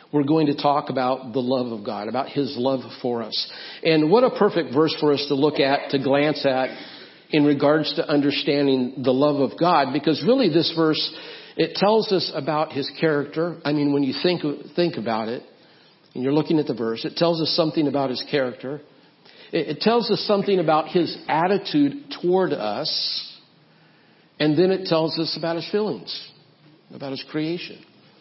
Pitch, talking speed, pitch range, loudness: 150 Hz, 185 wpm, 140-170 Hz, -22 LUFS